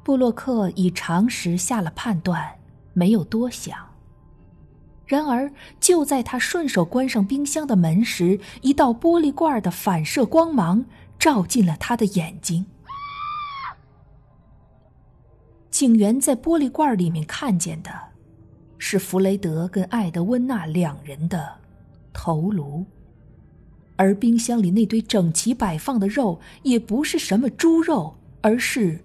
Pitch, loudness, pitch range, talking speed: 220 Hz, -21 LUFS, 180-270 Hz, 190 characters per minute